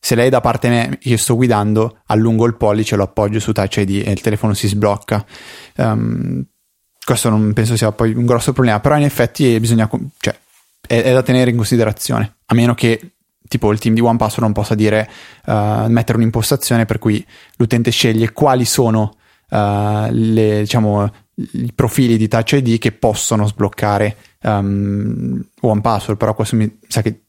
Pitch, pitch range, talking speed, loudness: 110 Hz, 105-120 Hz, 185 wpm, -15 LUFS